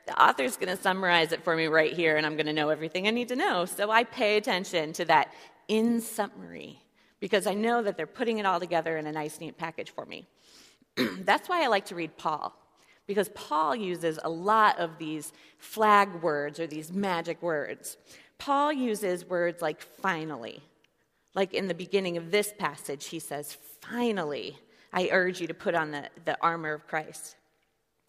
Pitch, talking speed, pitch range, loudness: 175 Hz, 190 wpm, 155-205 Hz, -28 LUFS